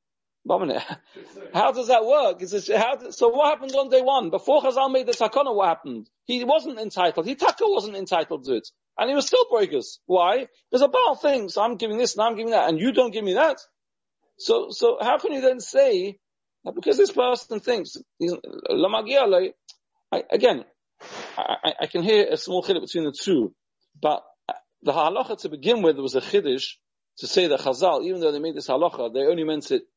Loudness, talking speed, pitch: -22 LUFS, 200 wpm, 260 Hz